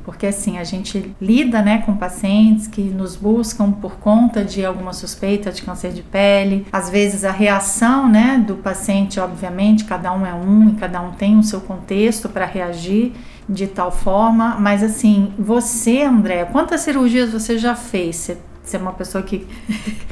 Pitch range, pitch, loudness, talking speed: 190-220 Hz, 200 Hz, -17 LUFS, 175 wpm